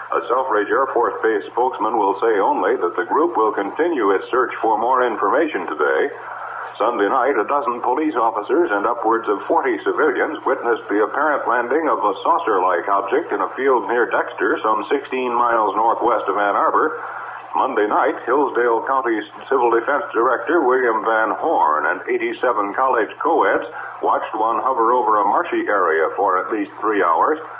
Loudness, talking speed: -18 LUFS, 170 wpm